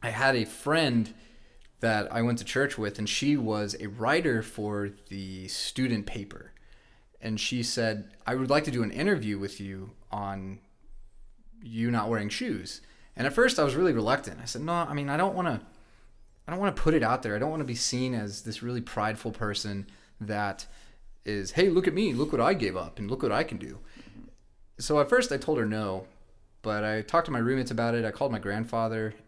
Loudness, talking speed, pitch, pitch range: -29 LUFS, 220 wpm, 115 Hz, 105-130 Hz